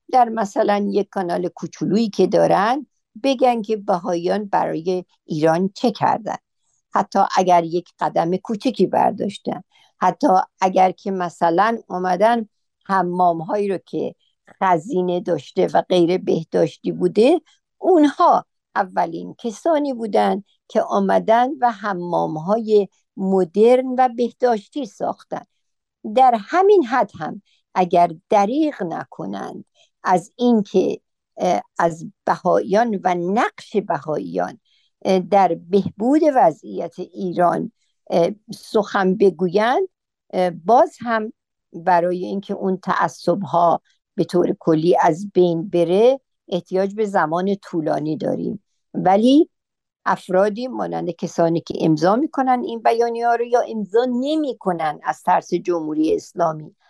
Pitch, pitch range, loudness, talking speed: 195 Hz, 175-230 Hz, -19 LUFS, 110 wpm